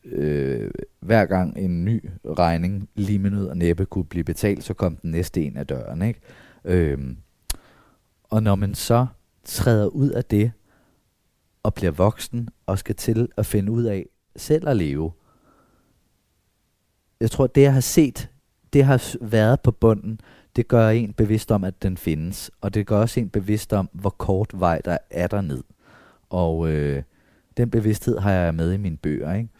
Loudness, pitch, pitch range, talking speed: -22 LUFS, 100 Hz, 90-115 Hz, 175 wpm